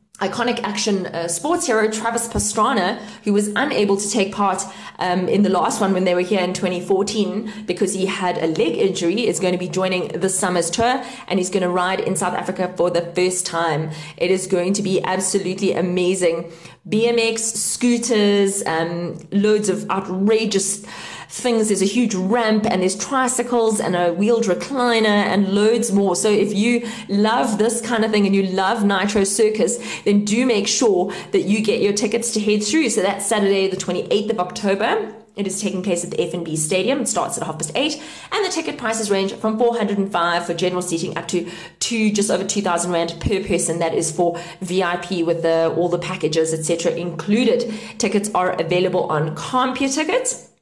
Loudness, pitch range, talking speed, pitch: -19 LUFS, 180-220 Hz, 190 wpm, 195 Hz